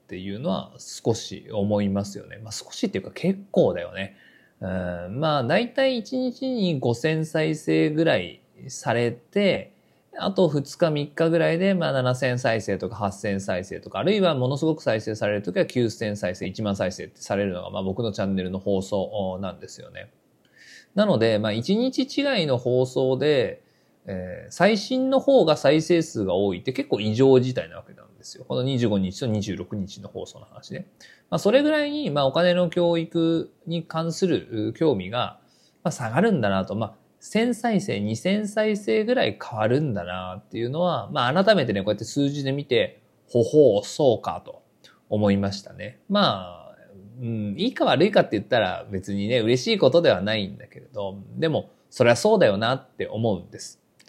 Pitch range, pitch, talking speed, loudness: 100-170 Hz, 125 Hz, 325 characters per minute, -24 LUFS